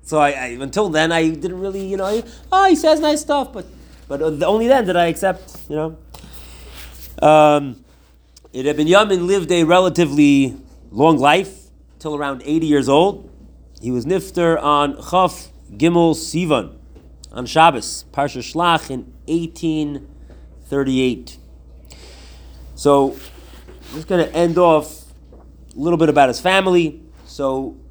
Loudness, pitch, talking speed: -17 LUFS, 150 Hz, 140 wpm